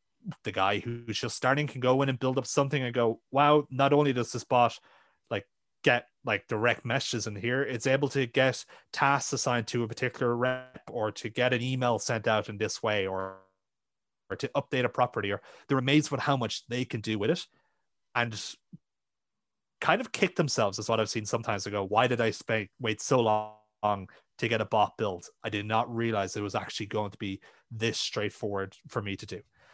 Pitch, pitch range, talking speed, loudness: 120 Hz, 105-130 Hz, 210 wpm, -29 LUFS